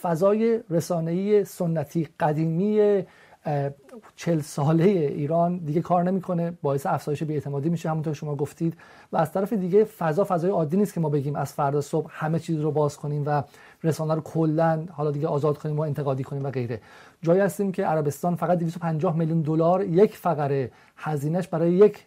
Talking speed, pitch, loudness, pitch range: 170 wpm, 165 Hz, -25 LUFS, 150-180 Hz